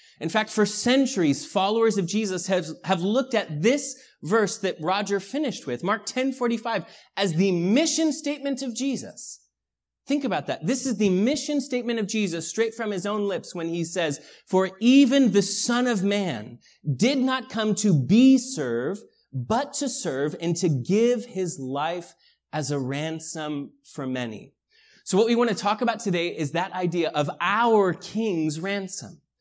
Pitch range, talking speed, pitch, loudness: 170-240 Hz, 170 wpm, 205 Hz, -24 LUFS